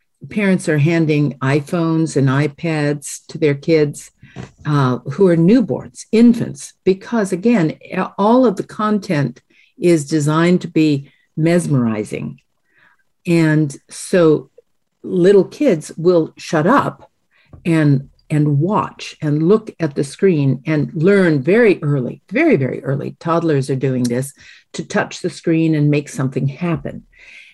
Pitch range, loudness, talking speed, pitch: 145-180 Hz, -16 LUFS, 130 wpm, 160 Hz